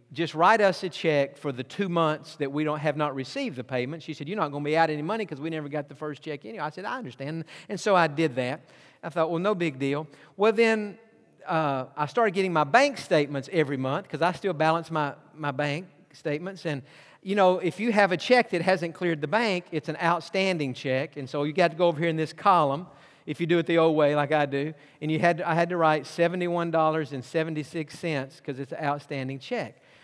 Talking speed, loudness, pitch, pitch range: 240 wpm, -26 LUFS, 160 Hz, 145-175 Hz